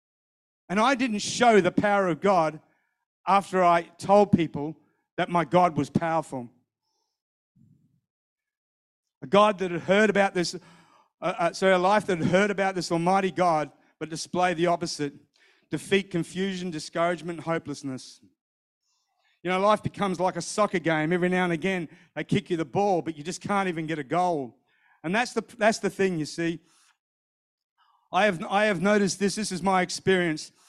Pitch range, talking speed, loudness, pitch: 165-200 Hz, 170 wpm, -25 LUFS, 180 Hz